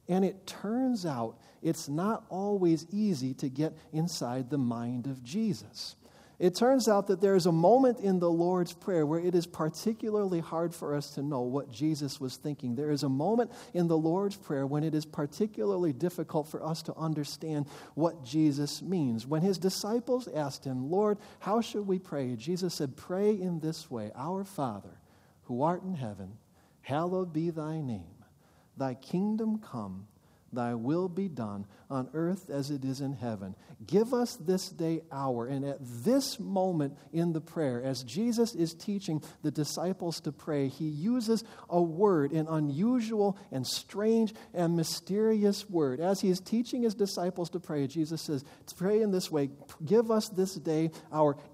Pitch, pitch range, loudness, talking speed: 165 Hz, 145-195 Hz, -31 LUFS, 175 wpm